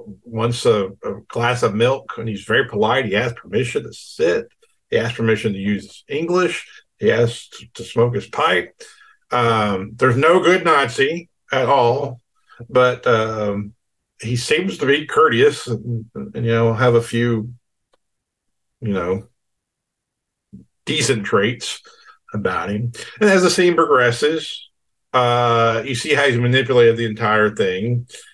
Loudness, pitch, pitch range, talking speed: -18 LUFS, 120 Hz, 110-140 Hz, 145 wpm